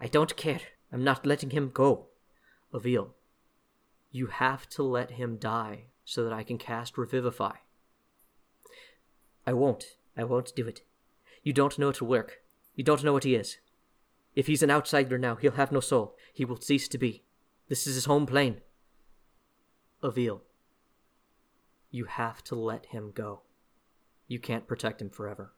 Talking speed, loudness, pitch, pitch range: 160 wpm, -30 LUFS, 125 Hz, 115-140 Hz